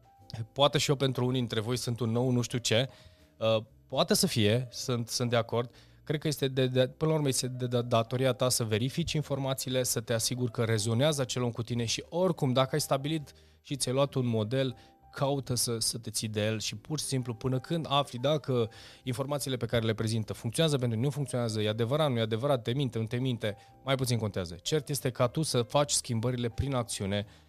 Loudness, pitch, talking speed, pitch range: -30 LUFS, 125 Hz, 225 wpm, 115-135 Hz